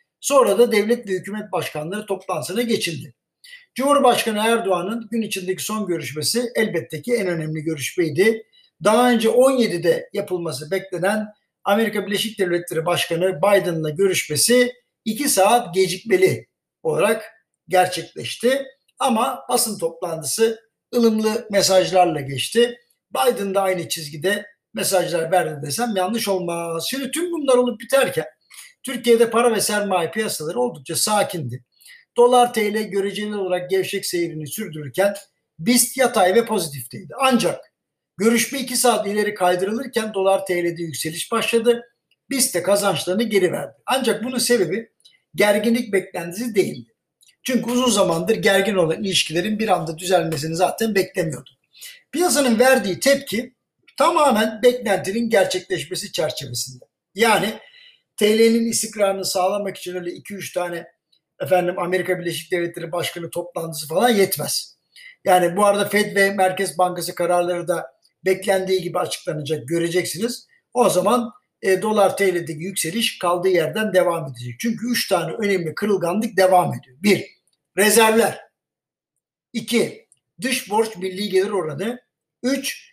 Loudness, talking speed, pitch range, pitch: -20 LUFS, 120 wpm, 175-230 Hz, 195 Hz